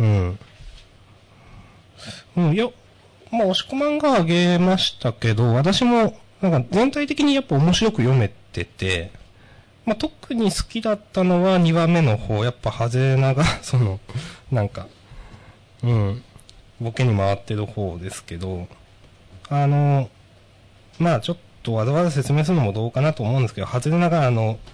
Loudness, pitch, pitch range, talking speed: -21 LUFS, 125 Hz, 105-170 Hz, 280 characters per minute